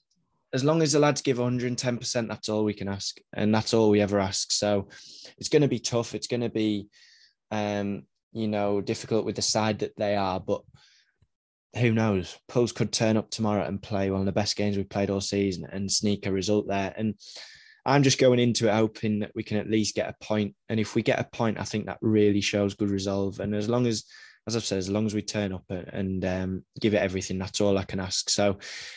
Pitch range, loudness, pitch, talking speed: 100-115 Hz, -27 LUFS, 105 Hz, 240 wpm